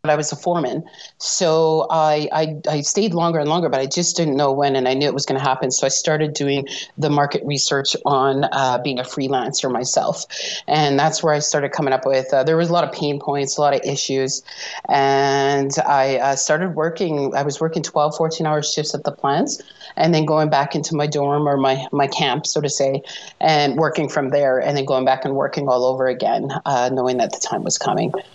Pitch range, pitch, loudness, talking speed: 135-155 Hz, 145 Hz, -19 LUFS, 230 wpm